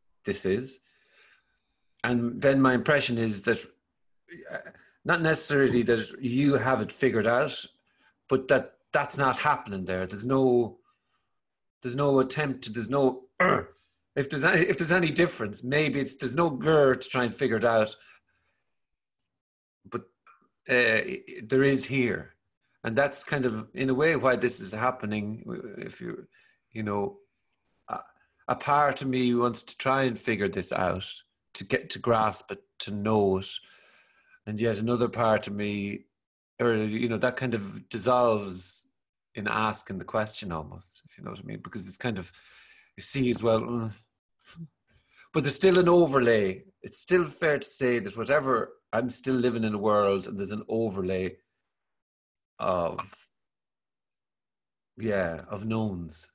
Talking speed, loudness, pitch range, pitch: 155 wpm, -27 LUFS, 110-135 Hz, 120 Hz